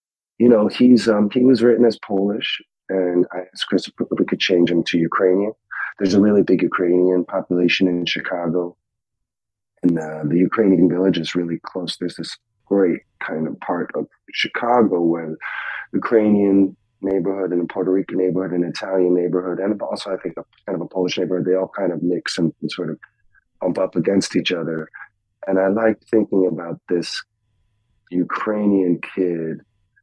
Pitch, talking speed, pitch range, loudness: 95 Hz, 175 wpm, 90-105 Hz, -19 LUFS